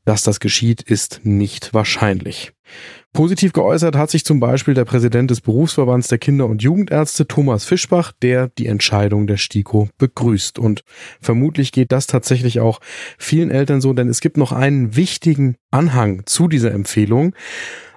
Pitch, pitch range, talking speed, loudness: 125 Hz, 110-150 Hz, 155 wpm, -16 LUFS